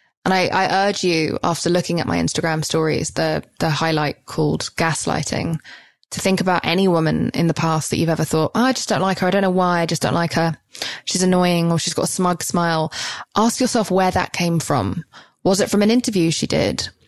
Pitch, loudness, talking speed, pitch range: 175 Hz, -19 LUFS, 225 wpm, 160-190 Hz